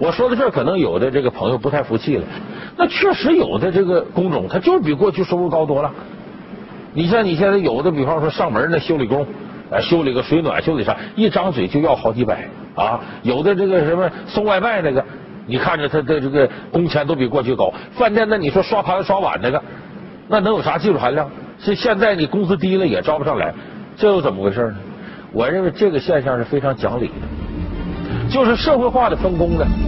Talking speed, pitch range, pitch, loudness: 315 characters per minute, 155-210 Hz, 185 Hz, -18 LUFS